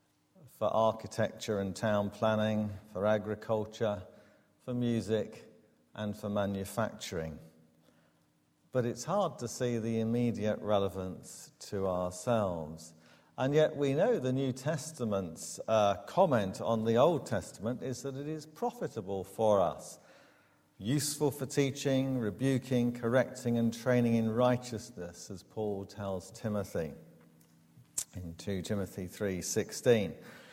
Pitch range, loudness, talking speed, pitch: 100-125 Hz, -33 LUFS, 115 wpm, 110 Hz